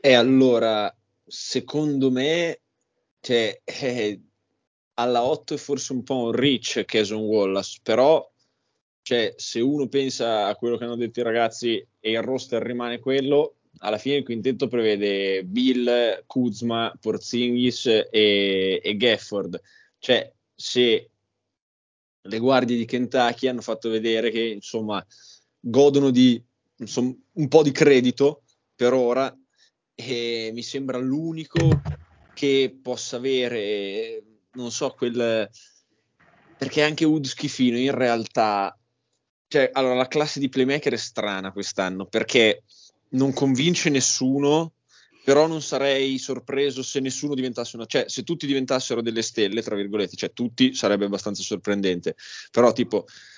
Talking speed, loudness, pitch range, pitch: 130 wpm, -23 LUFS, 115-135 Hz, 125 Hz